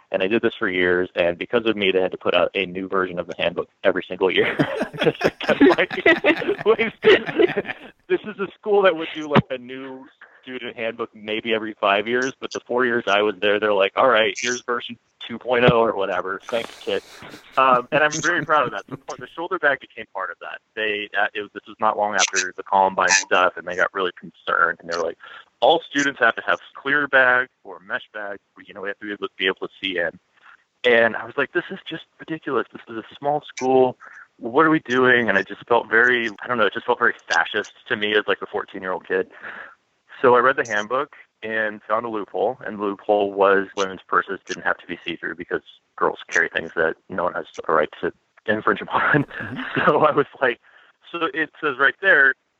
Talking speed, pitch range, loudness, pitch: 225 wpm, 105-140 Hz, -21 LUFS, 115 Hz